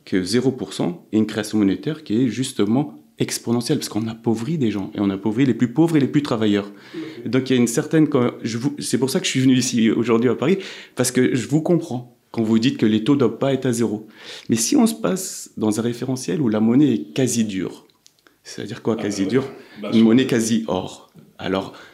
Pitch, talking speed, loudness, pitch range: 120 Hz, 220 wpm, -20 LUFS, 110-135 Hz